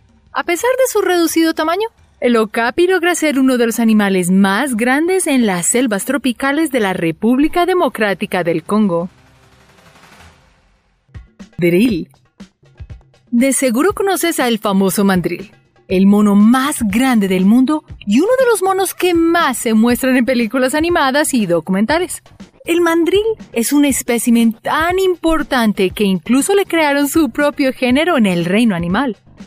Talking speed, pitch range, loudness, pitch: 145 wpm, 210-325 Hz, -14 LUFS, 255 Hz